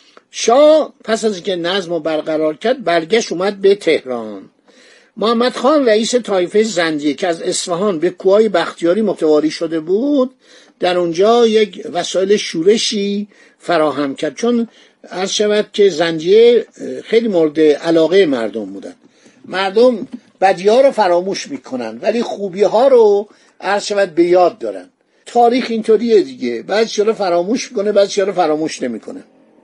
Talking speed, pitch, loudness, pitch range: 140 wpm, 200 Hz, -15 LUFS, 175-235 Hz